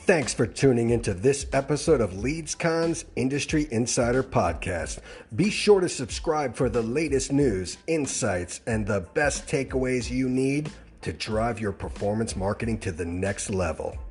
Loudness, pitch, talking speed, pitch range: -26 LUFS, 120 Hz, 150 wpm, 100-140 Hz